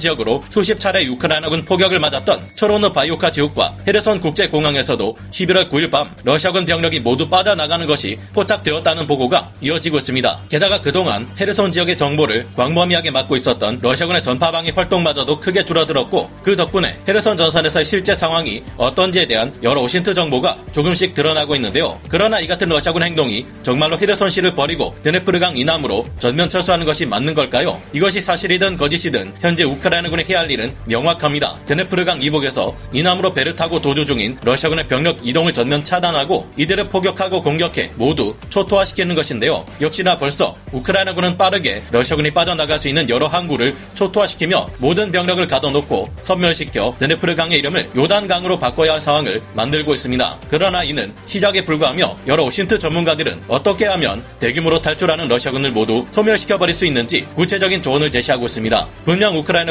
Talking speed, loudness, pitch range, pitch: 455 characters per minute, -15 LUFS, 145-185 Hz, 165 Hz